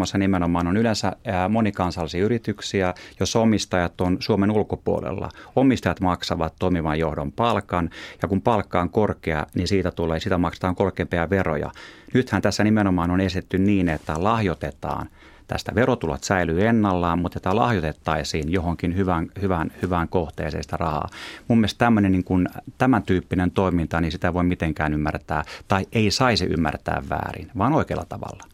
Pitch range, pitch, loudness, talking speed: 85-100 Hz, 90 Hz, -23 LUFS, 140 wpm